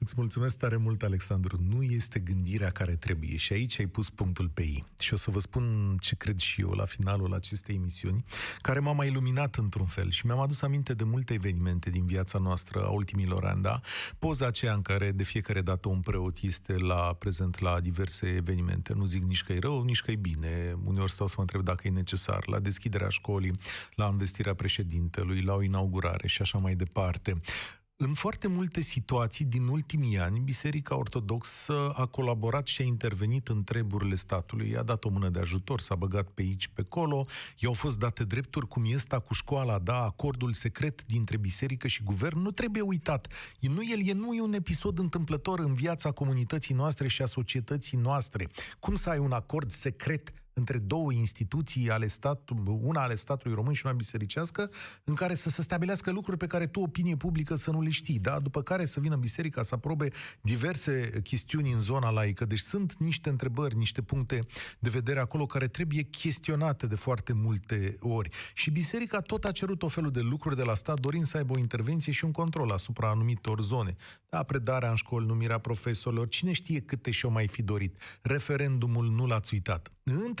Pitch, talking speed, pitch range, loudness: 120 Hz, 195 wpm, 100-140 Hz, -31 LUFS